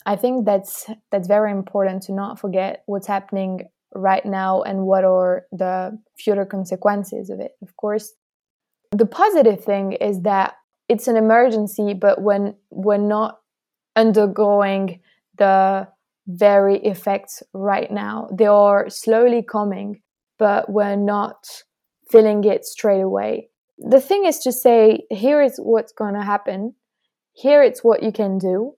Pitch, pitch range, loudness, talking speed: 205 Hz, 195-225 Hz, -18 LUFS, 145 wpm